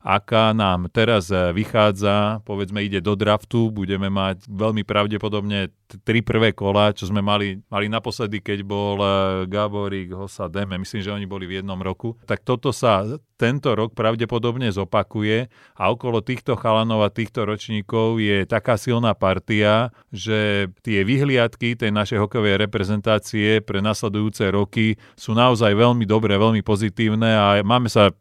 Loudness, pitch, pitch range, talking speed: -21 LUFS, 105 Hz, 100-115 Hz, 150 wpm